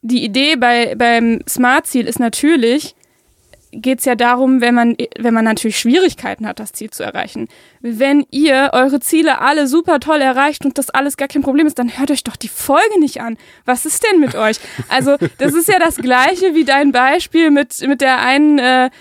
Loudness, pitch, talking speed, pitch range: -13 LUFS, 265 Hz, 200 wpm, 240-295 Hz